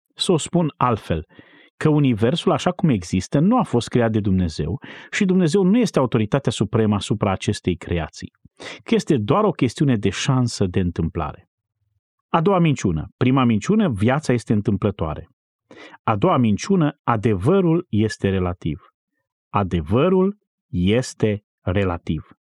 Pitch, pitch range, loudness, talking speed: 120 Hz, 100-160 Hz, -20 LUFS, 135 wpm